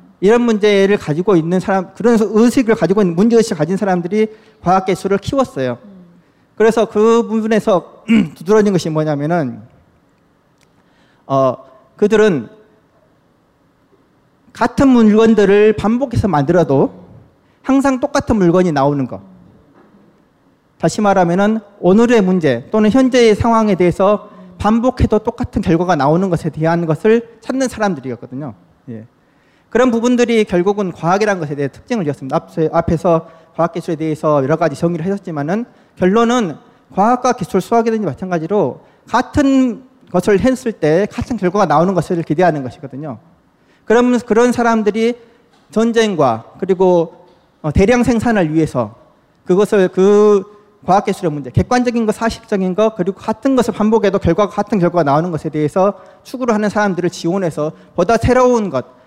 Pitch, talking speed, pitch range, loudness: 195 Hz, 325 characters per minute, 165-225 Hz, -14 LUFS